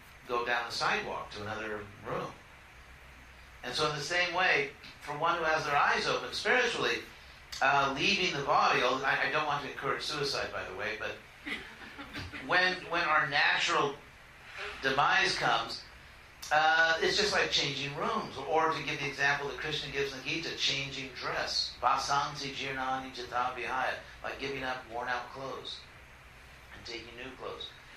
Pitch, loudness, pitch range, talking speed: 135 Hz, -30 LUFS, 120-150 Hz, 155 wpm